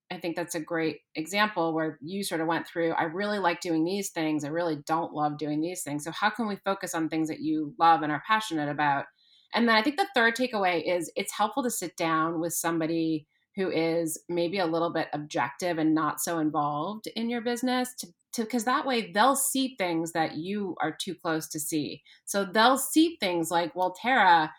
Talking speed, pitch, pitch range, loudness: 215 wpm, 170 Hz, 160-210 Hz, -28 LUFS